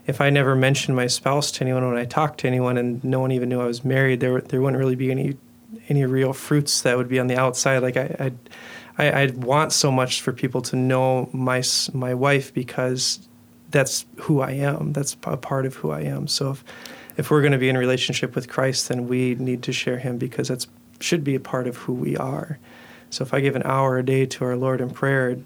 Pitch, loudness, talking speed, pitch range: 130 Hz, -22 LUFS, 245 wpm, 125-140 Hz